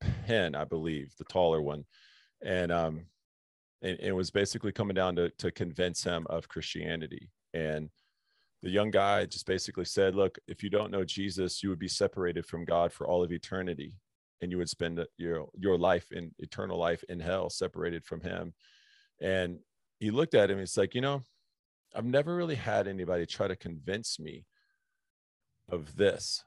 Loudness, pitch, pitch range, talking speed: -32 LUFS, 95 Hz, 85-105 Hz, 180 wpm